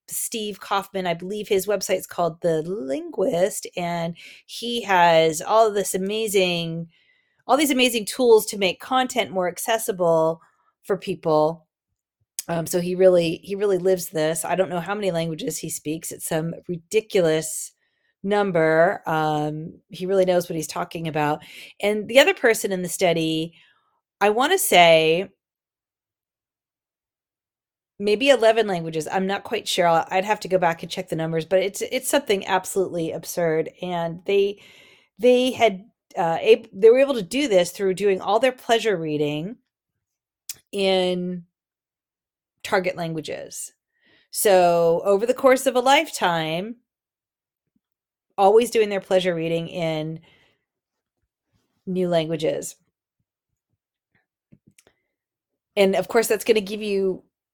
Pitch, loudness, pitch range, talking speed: 185 Hz, -21 LUFS, 165-215 Hz, 140 wpm